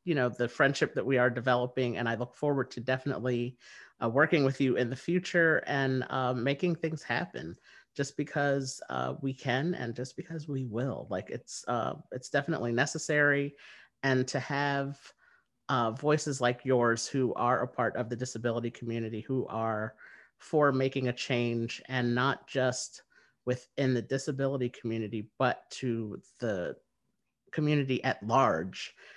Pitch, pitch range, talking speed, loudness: 130 Hz, 120-140 Hz, 155 wpm, -31 LUFS